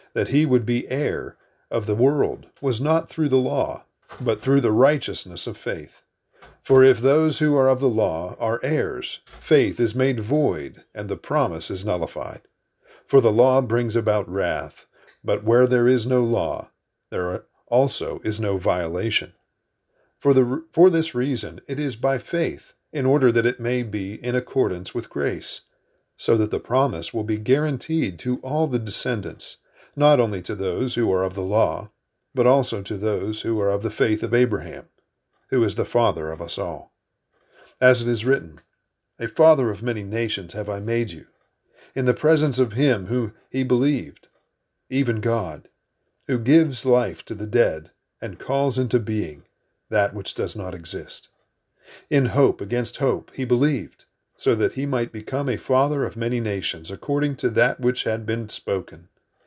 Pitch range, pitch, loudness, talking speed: 110-135 Hz, 125 Hz, -22 LUFS, 175 wpm